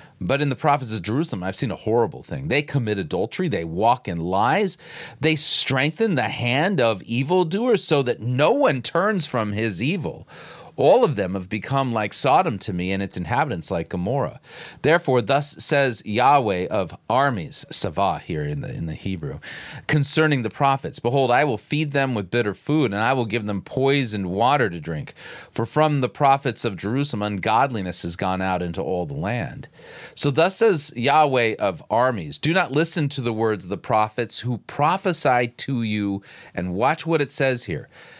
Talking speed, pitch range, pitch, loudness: 185 wpm, 105-150 Hz, 130 Hz, -22 LUFS